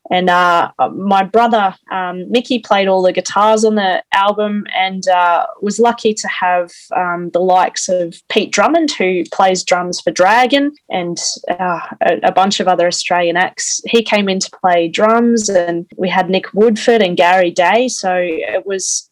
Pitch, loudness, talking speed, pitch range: 190 Hz, -14 LUFS, 175 wpm, 180-215 Hz